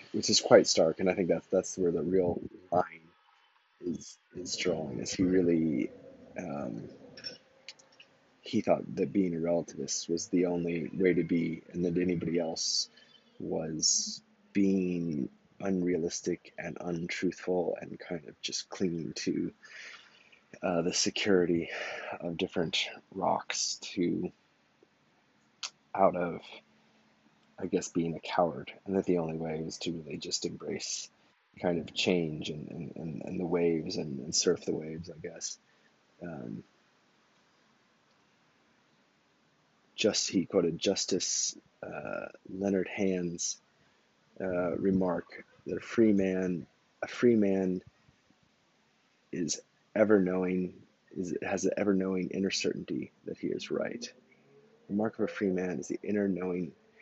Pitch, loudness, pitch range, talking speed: 90 Hz, -32 LUFS, 85-95 Hz, 135 wpm